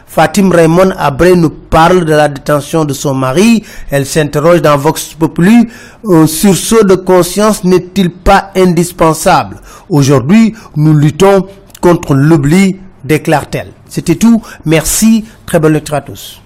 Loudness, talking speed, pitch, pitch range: -9 LUFS, 140 wpm, 165 Hz, 150-190 Hz